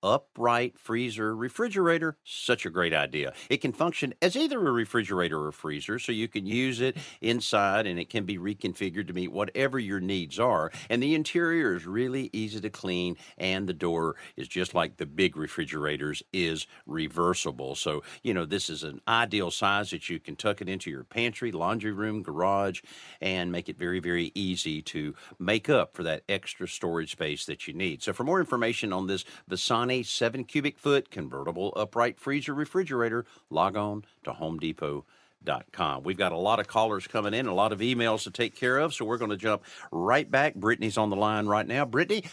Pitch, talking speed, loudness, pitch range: 105 Hz, 195 wpm, -29 LUFS, 90-120 Hz